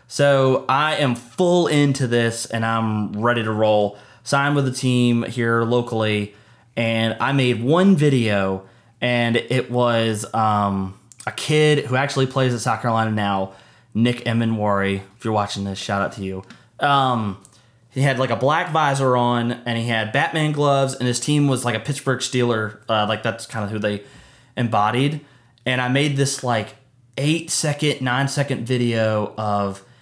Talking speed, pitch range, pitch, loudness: 170 wpm, 110-135 Hz, 120 Hz, -20 LUFS